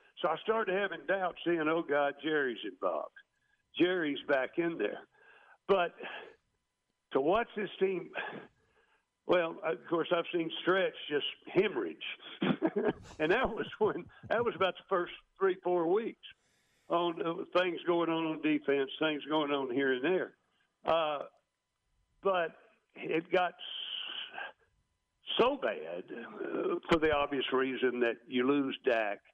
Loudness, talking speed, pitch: -33 LUFS, 135 wpm, 180 Hz